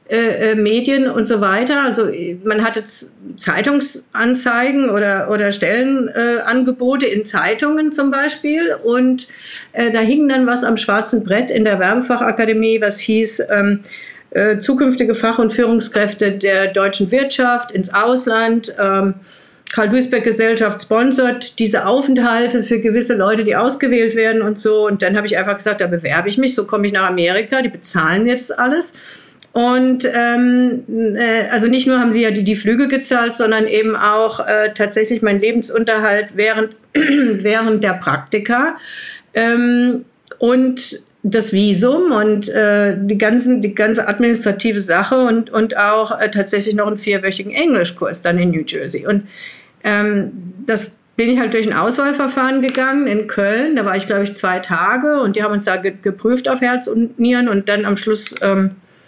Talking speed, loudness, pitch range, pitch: 165 wpm, -15 LUFS, 210-245 Hz, 225 Hz